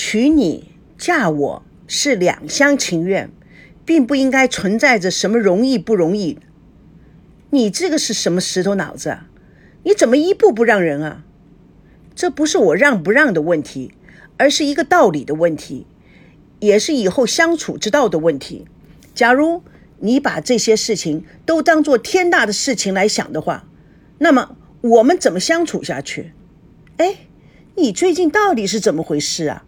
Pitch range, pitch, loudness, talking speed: 185-310 Hz, 240 Hz, -16 LUFS, 235 characters per minute